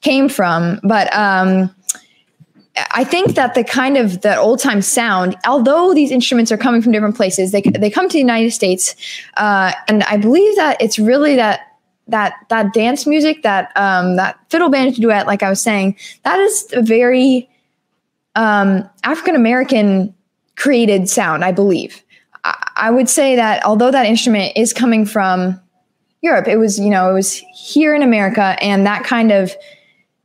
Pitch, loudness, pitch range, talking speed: 225 Hz, -13 LUFS, 195-260 Hz, 170 wpm